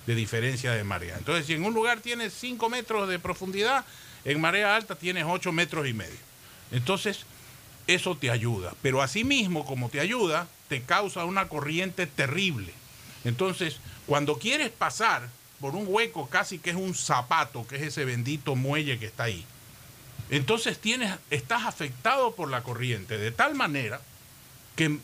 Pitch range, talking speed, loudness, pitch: 125-185 Hz, 160 wpm, -28 LUFS, 150 Hz